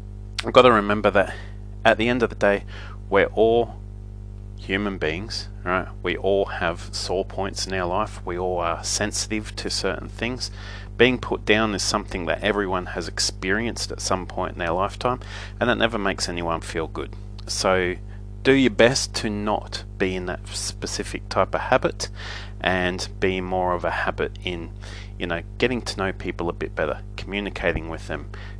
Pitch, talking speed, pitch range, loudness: 100 Hz, 180 wpm, 95-105 Hz, -23 LUFS